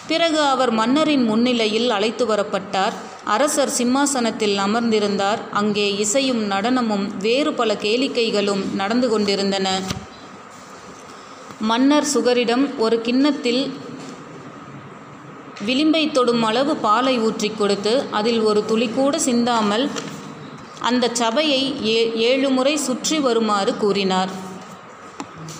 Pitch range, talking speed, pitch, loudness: 210-255 Hz, 90 wpm, 235 Hz, -19 LUFS